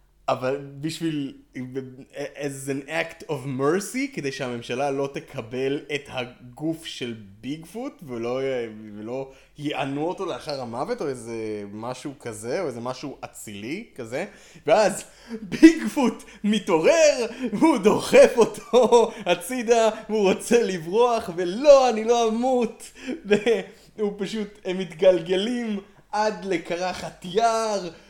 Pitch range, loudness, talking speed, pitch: 135-225 Hz, -23 LUFS, 115 wpm, 175 Hz